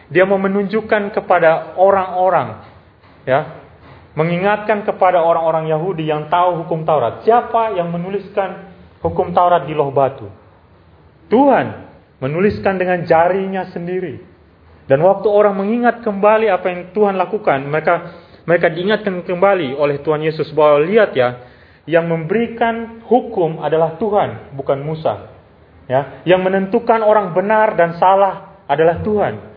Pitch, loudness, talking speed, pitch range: 175 Hz, -16 LUFS, 125 wpm, 150-200 Hz